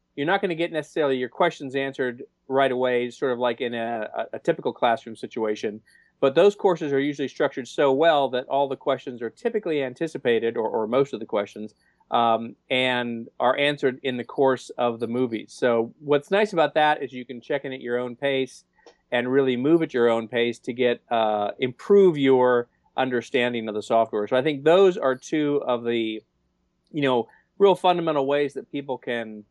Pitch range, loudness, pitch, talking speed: 120-145 Hz, -24 LUFS, 130 Hz, 200 wpm